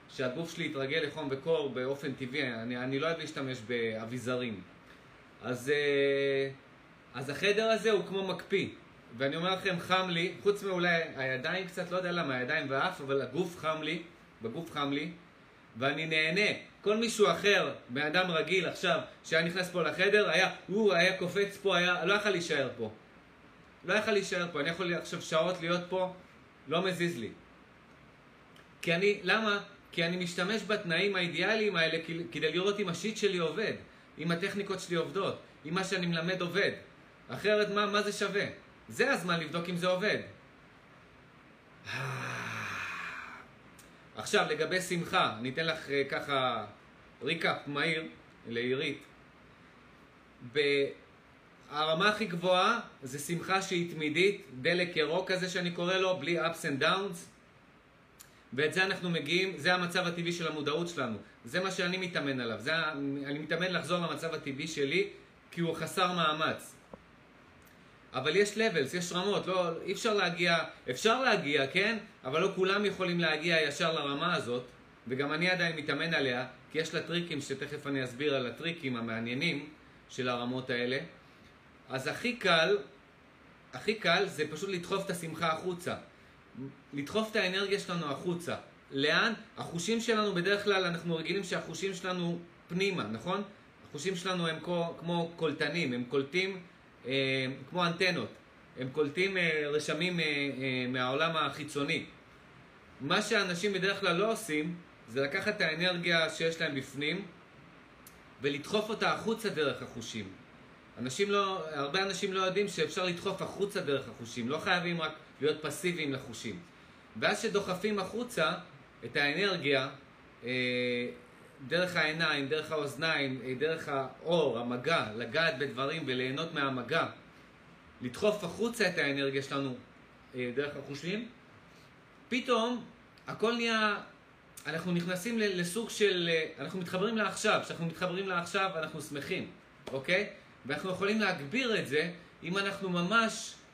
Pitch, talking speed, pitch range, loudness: 170 Hz, 135 wpm, 140-190 Hz, -32 LUFS